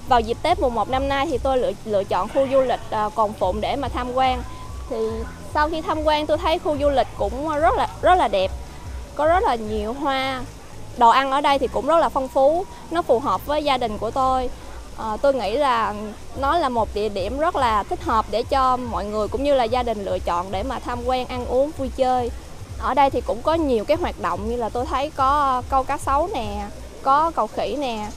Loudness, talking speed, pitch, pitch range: -21 LUFS, 245 wpm, 265 Hz, 240-295 Hz